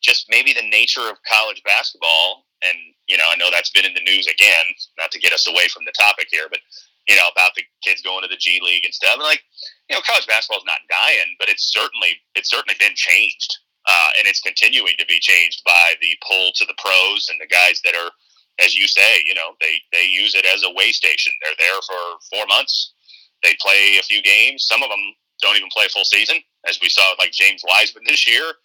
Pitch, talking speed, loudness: 95 Hz, 240 wpm, -14 LUFS